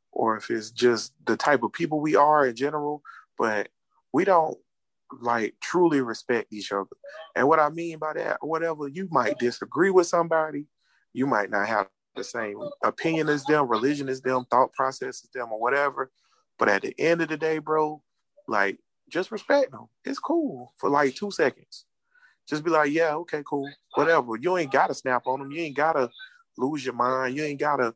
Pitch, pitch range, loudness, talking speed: 150 Hz, 130-165 Hz, -25 LUFS, 200 wpm